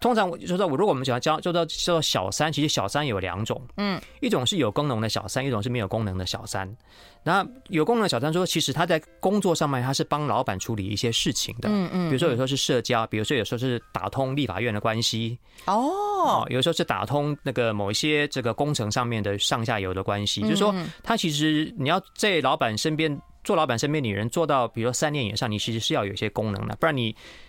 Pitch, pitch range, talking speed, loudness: 130 Hz, 110-160 Hz, 365 characters per minute, -25 LUFS